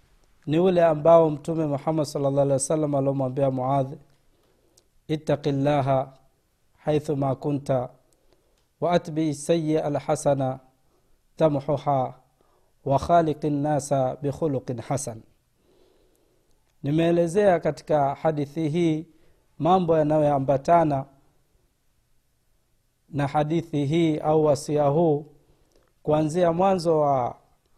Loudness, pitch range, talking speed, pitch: -24 LUFS, 140-160 Hz, 80 wpm, 150 Hz